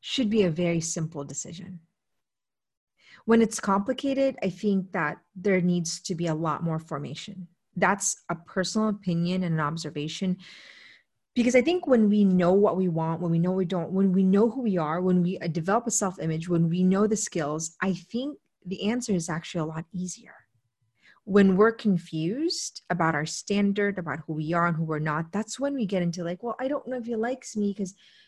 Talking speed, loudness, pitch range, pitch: 200 wpm, -26 LUFS, 170-210 Hz, 185 Hz